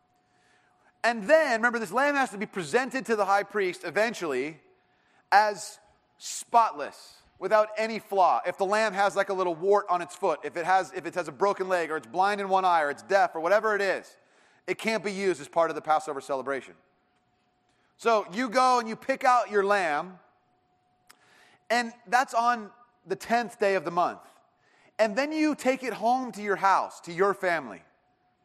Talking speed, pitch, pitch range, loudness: 195 wpm, 205 Hz, 185-230 Hz, -26 LUFS